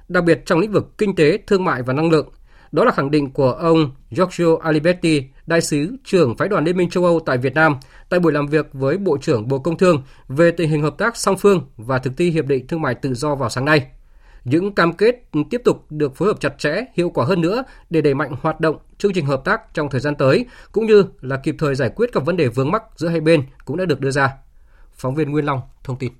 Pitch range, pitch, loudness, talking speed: 135-175 Hz, 155 Hz, -18 LUFS, 260 wpm